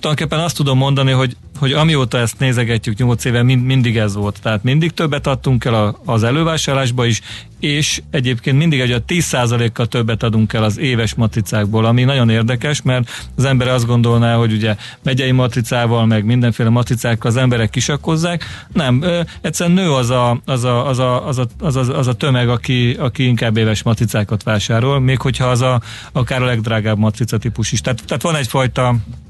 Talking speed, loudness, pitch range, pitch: 160 wpm, -15 LUFS, 115-135 Hz, 125 Hz